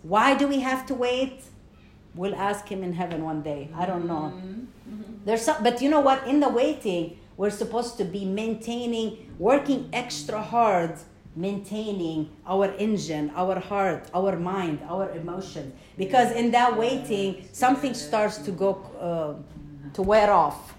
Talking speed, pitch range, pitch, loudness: 155 wpm, 180-240 Hz, 200 Hz, -25 LUFS